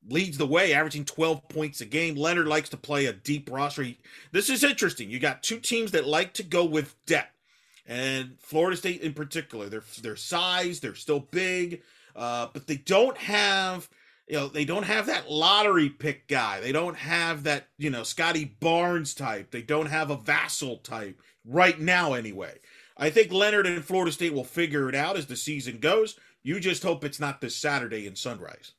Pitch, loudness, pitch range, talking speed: 155 Hz, -26 LUFS, 140-175 Hz, 200 wpm